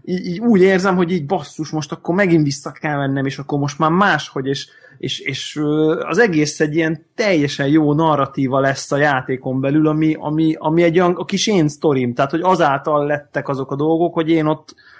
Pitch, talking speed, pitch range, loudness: 155 Hz, 195 wpm, 145-170 Hz, -17 LUFS